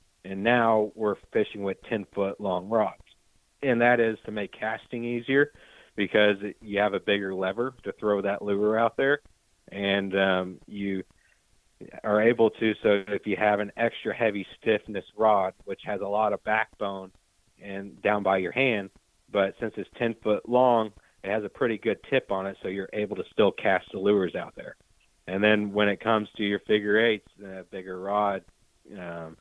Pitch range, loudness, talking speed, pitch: 95-110 Hz, -26 LUFS, 185 wpm, 105 Hz